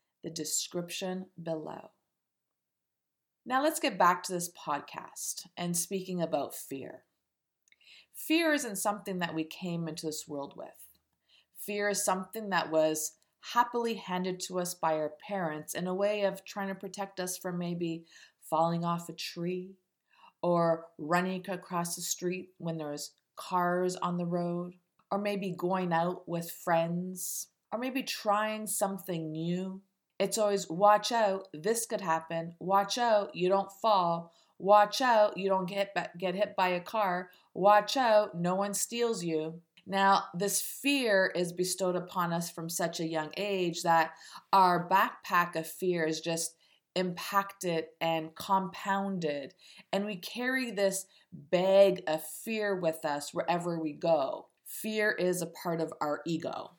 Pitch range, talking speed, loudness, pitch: 165-200 Hz, 150 wpm, -31 LUFS, 180 Hz